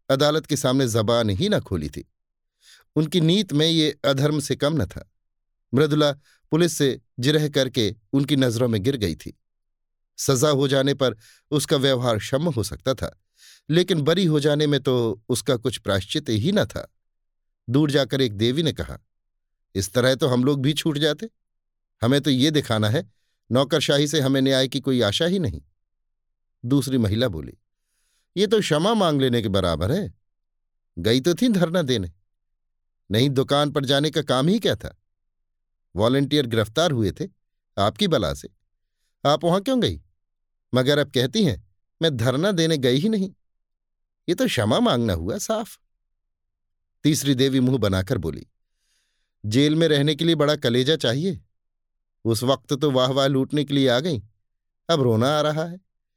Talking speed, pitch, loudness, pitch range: 170 wpm, 130 Hz, -22 LUFS, 100-150 Hz